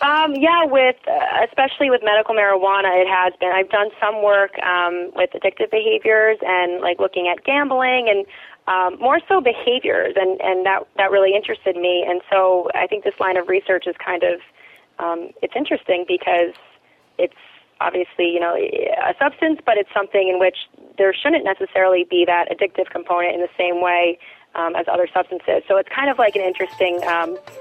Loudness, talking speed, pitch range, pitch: -18 LUFS, 185 wpm, 180-225 Hz, 195 Hz